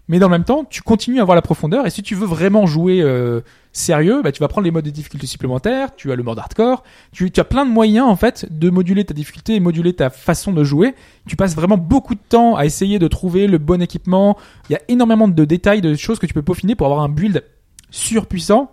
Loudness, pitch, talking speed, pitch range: -16 LUFS, 185 Hz, 260 wpm, 155-215 Hz